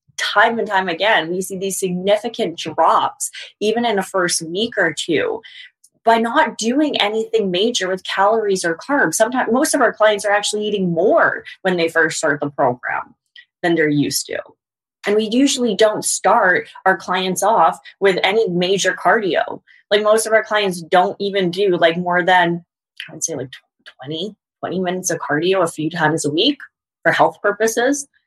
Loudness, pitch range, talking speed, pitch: -17 LUFS, 180-220 Hz, 180 wpm, 195 Hz